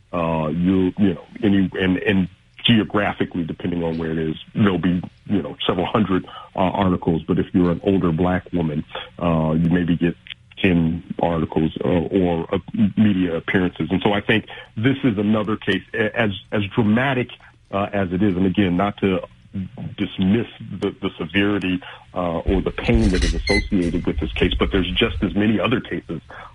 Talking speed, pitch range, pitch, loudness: 180 wpm, 85-105 Hz, 95 Hz, -21 LUFS